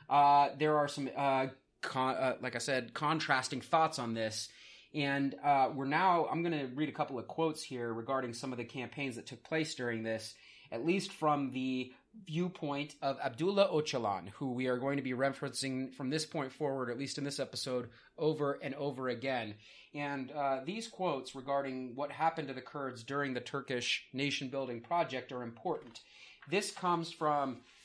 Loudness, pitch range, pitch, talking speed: -35 LUFS, 130-150 Hz, 135 Hz, 185 wpm